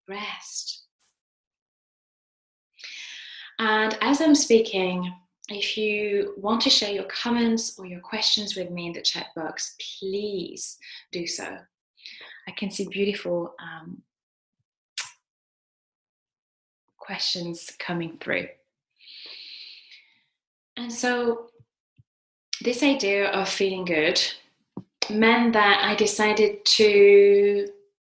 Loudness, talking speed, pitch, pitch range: -23 LUFS, 95 wpm, 205 Hz, 180-235 Hz